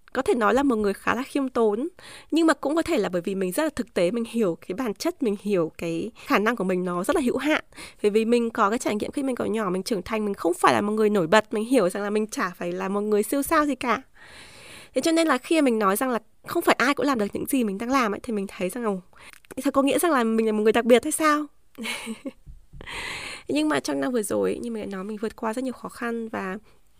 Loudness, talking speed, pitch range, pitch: -24 LUFS, 295 wpm, 205-275 Hz, 230 Hz